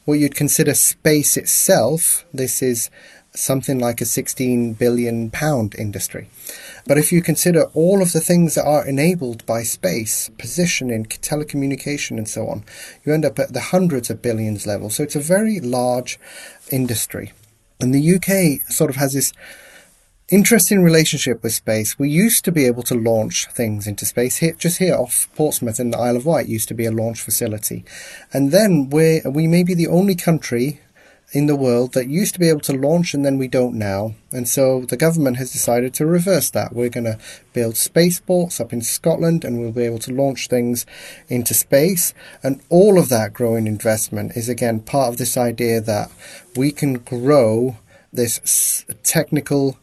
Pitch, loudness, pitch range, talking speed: 130 Hz, -18 LUFS, 115-155 Hz, 185 wpm